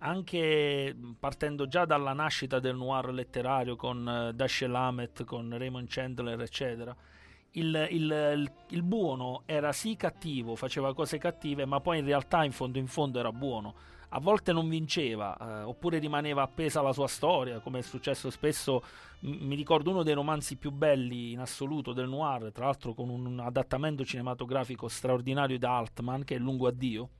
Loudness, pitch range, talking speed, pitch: -32 LUFS, 125-150 Hz, 175 wpm, 135 Hz